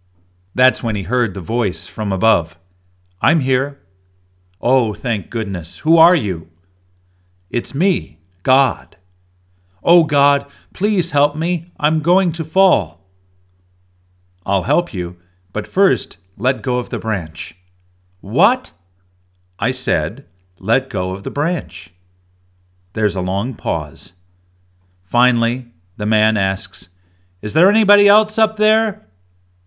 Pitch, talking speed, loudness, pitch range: 95 Hz, 120 wpm, -17 LUFS, 90-130 Hz